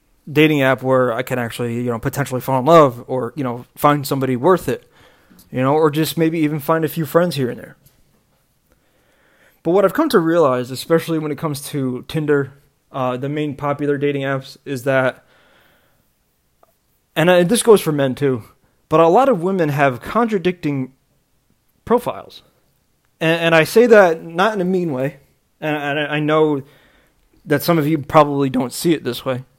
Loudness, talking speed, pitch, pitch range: -17 LUFS, 185 wpm, 145 Hz, 130-165 Hz